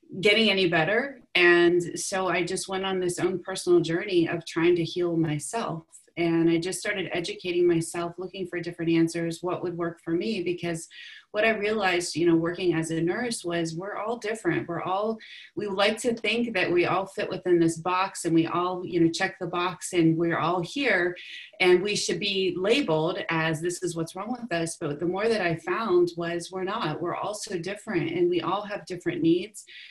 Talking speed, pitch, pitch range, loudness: 205 wpm, 175 Hz, 170-190 Hz, -26 LUFS